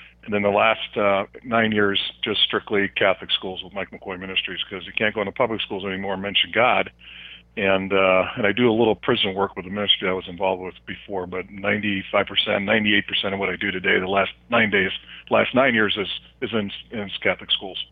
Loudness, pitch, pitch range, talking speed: -21 LUFS, 100 Hz, 95-100 Hz, 215 wpm